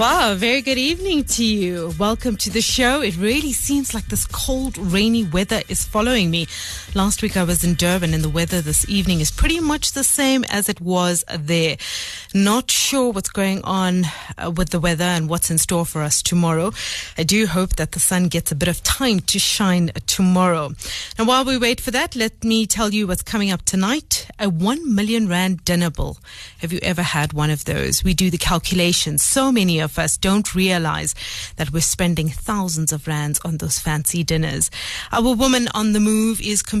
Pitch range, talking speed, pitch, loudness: 170-220 Hz, 200 wpm, 185 Hz, -19 LUFS